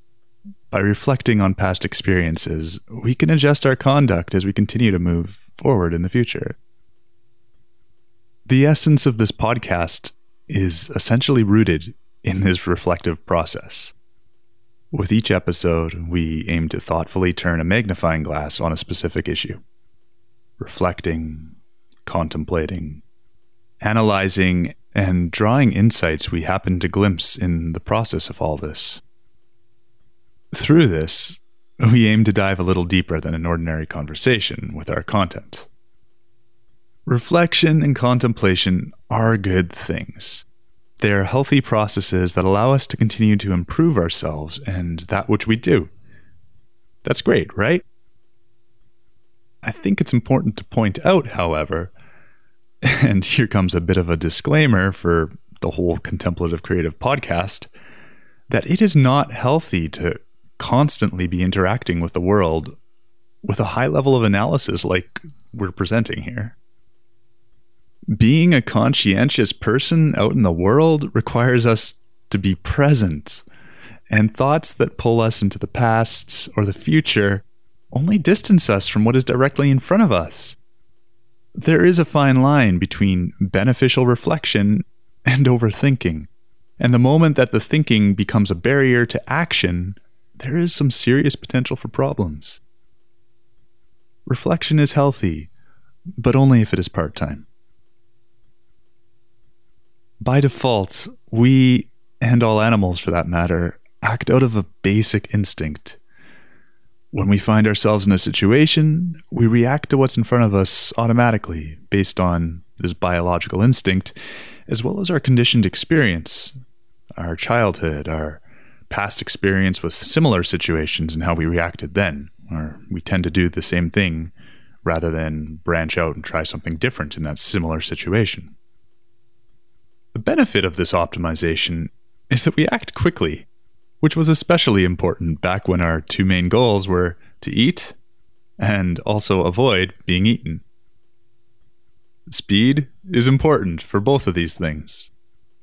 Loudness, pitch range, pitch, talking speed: -18 LUFS, 90-120 Hz, 110 Hz, 135 wpm